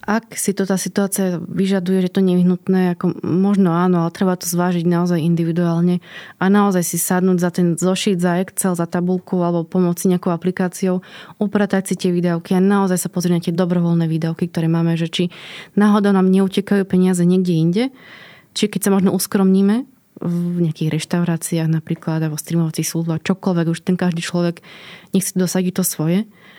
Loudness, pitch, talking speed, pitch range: -18 LUFS, 180 Hz, 170 wpm, 170-190 Hz